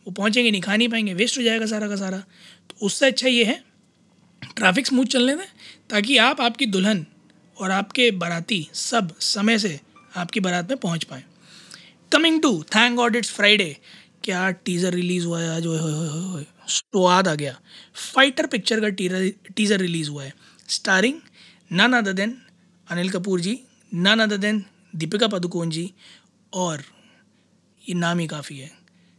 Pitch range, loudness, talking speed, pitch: 180-225 Hz, -21 LUFS, 155 wpm, 195 Hz